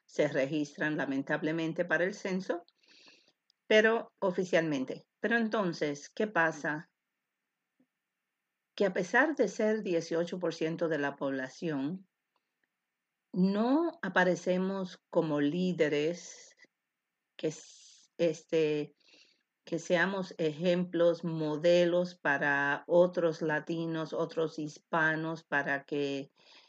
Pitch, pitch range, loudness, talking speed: 170 Hz, 155-195 Hz, -31 LUFS, 85 wpm